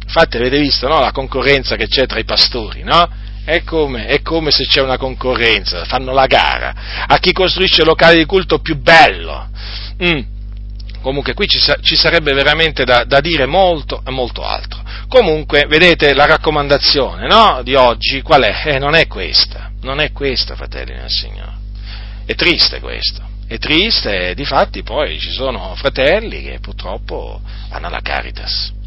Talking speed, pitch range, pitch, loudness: 170 wpm, 105-155 Hz, 130 Hz, -12 LUFS